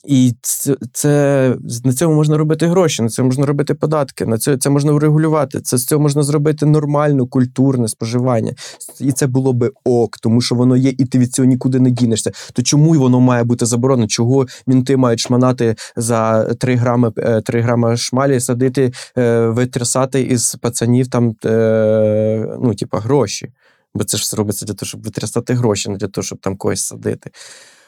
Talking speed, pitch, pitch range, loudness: 180 wpm, 125 Hz, 115-135 Hz, -15 LUFS